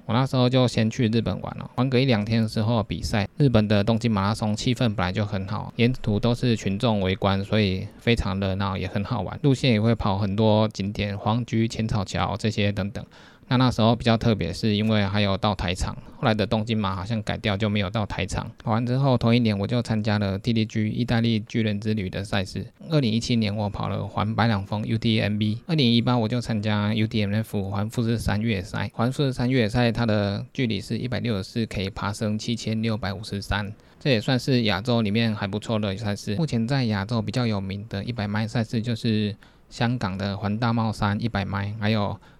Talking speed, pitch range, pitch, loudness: 330 characters per minute, 100-115 Hz, 110 Hz, -24 LUFS